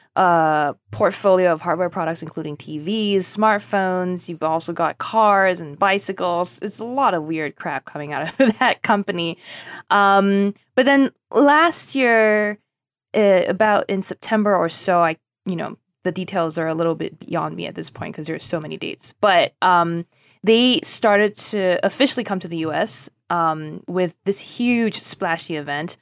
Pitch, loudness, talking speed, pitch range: 185 Hz, -19 LUFS, 165 wpm, 165-210 Hz